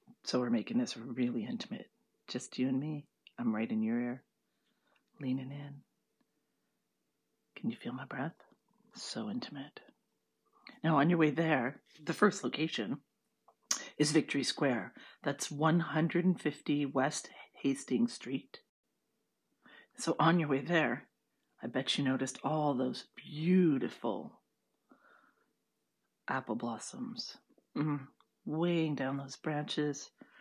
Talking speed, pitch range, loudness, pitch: 115 wpm, 135-175 Hz, -35 LUFS, 155 Hz